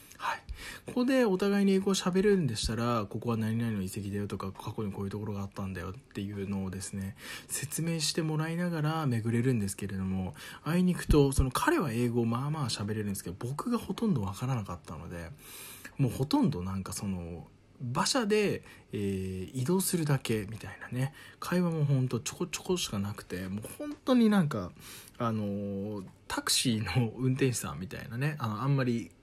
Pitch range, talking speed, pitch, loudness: 100-155 Hz, 395 characters per minute, 120 Hz, -31 LUFS